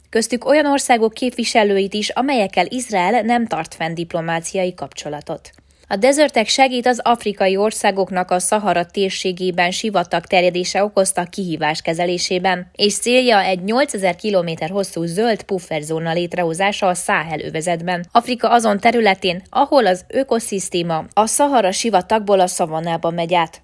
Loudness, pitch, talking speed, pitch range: -17 LUFS, 190 Hz, 125 wpm, 175-225 Hz